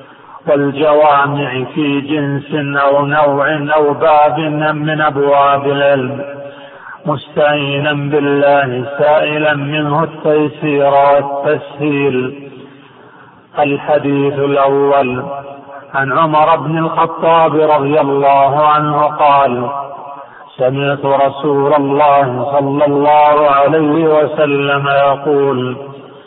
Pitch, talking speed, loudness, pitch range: 140 Hz, 80 wpm, -12 LUFS, 140-150 Hz